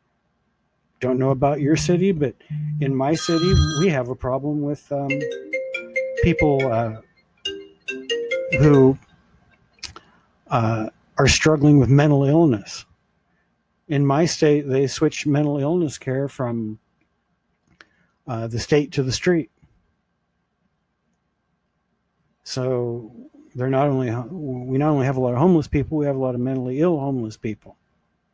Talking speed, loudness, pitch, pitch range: 130 wpm, -21 LUFS, 140 Hz, 130-160 Hz